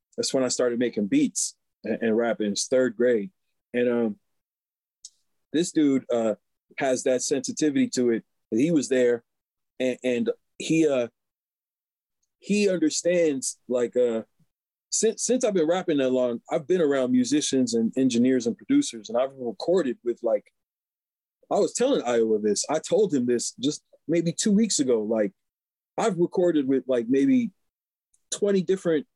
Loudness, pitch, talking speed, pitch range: -25 LUFS, 135 Hz, 155 wpm, 120-185 Hz